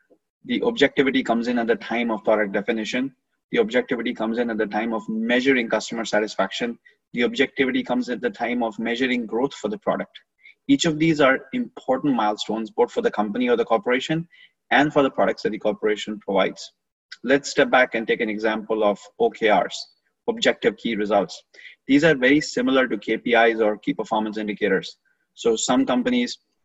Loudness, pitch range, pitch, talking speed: -22 LUFS, 110-140 Hz, 120 Hz, 180 wpm